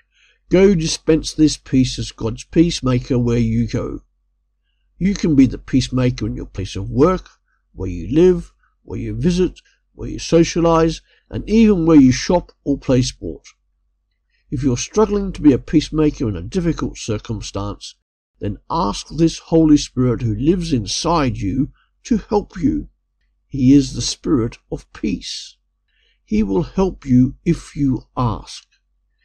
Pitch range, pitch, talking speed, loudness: 120-170 Hz, 140 Hz, 150 wpm, -18 LUFS